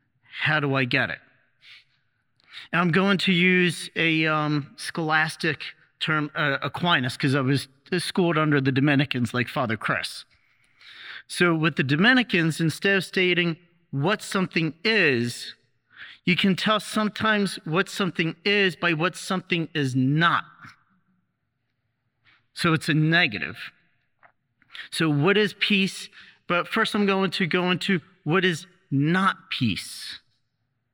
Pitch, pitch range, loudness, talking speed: 170 Hz, 145-190 Hz, -23 LUFS, 130 wpm